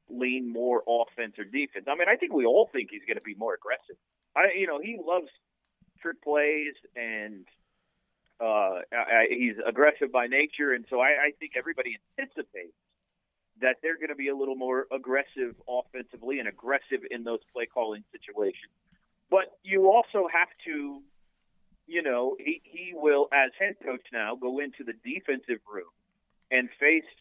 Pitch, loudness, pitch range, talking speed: 150 Hz, -28 LUFS, 125-195 Hz, 170 wpm